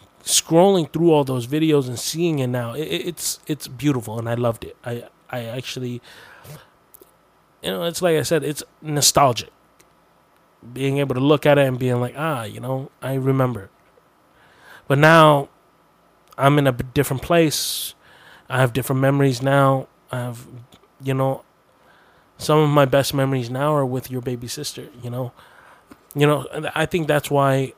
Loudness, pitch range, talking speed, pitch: -20 LUFS, 125-150 Hz, 170 wpm, 135 Hz